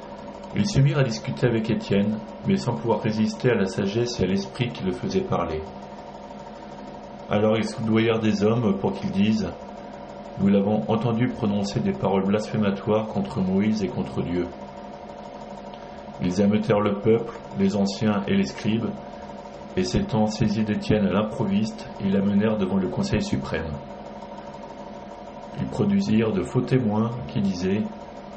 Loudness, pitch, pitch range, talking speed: -24 LUFS, 110 Hz, 100-115 Hz, 145 wpm